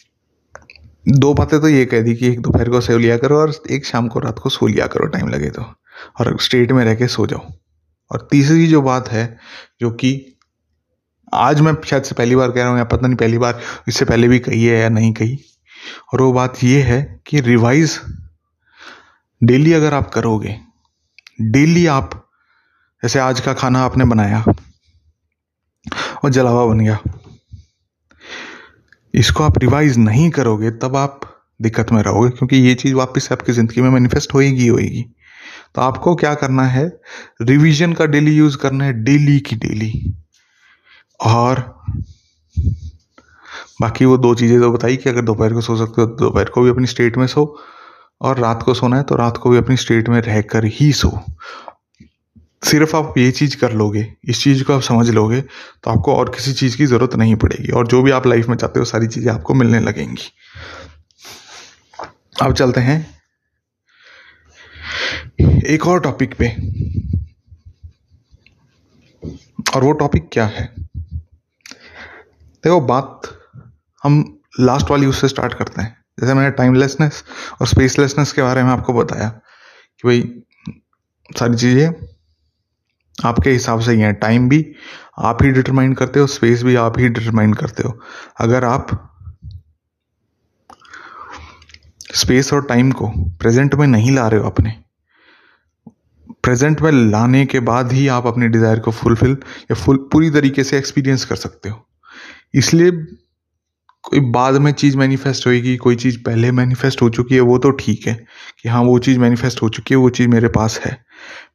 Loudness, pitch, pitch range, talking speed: -15 LUFS, 120 Hz, 110-135 Hz, 165 wpm